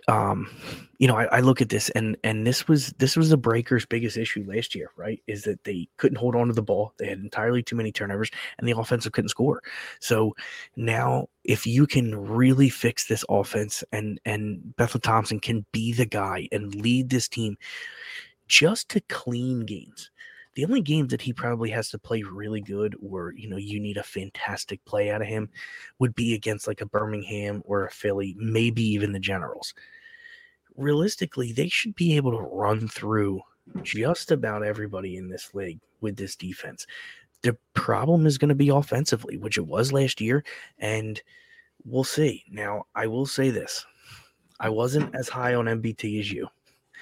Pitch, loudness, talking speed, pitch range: 115 Hz, -26 LUFS, 185 wpm, 105-130 Hz